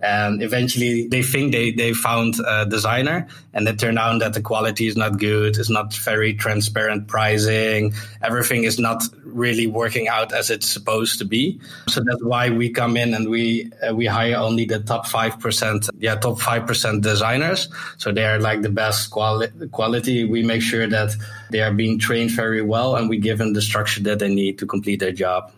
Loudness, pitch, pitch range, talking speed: -20 LUFS, 115 Hz, 110-115 Hz, 200 wpm